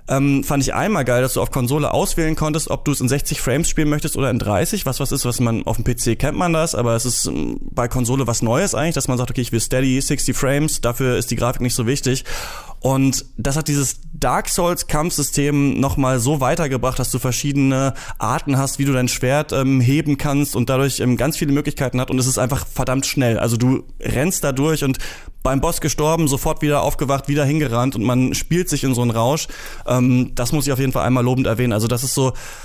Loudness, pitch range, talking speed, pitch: -19 LUFS, 125-145 Hz, 235 wpm, 135 Hz